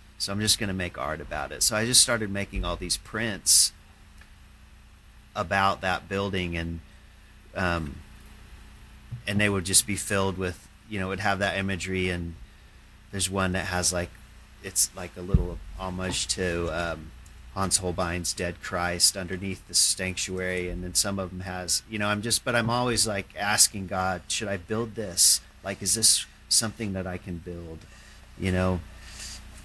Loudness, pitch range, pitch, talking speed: -25 LUFS, 85-100 Hz, 95 Hz, 175 wpm